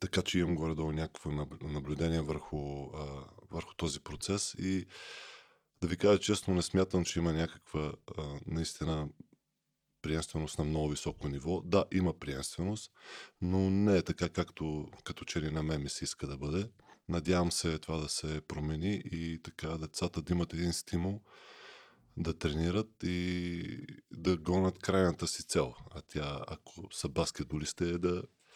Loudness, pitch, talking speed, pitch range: -35 LUFS, 85 Hz, 150 wpm, 75-90 Hz